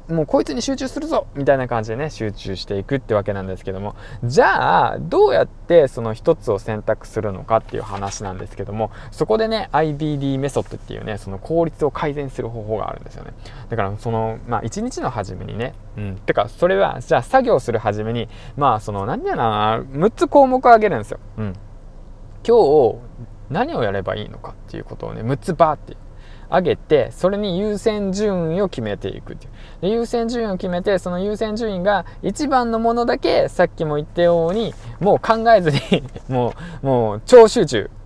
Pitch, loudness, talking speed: 135 Hz, -19 LUFS, 380 characters per minute